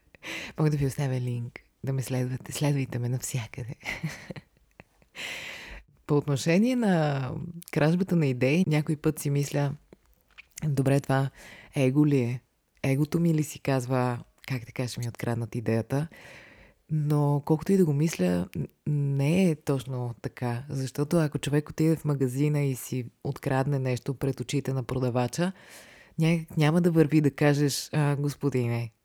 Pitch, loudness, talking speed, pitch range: 140 Hz, -28 LUFS, 140 wpm, 130-155 Hz